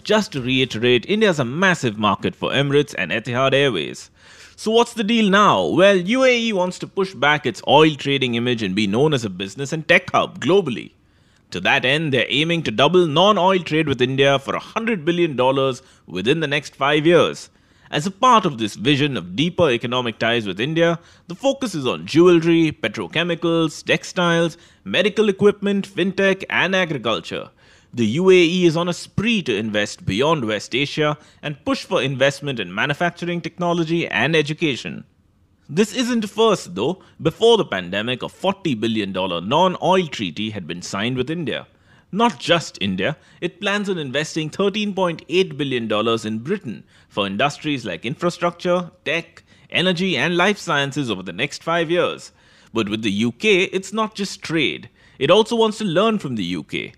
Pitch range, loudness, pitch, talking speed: 135-190 Hz, -19 LUFS, 165 Hz, 170 wpm